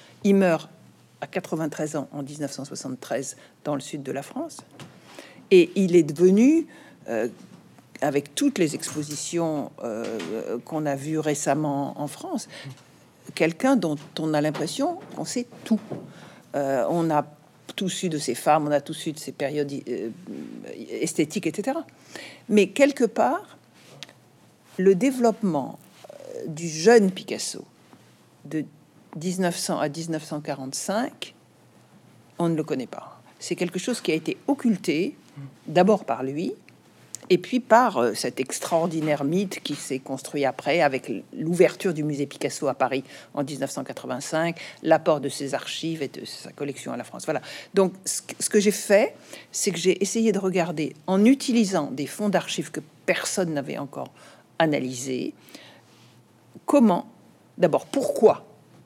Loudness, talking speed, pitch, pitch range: -25 LUFS, 140 wpm, 160 Hz, 145-200 Hz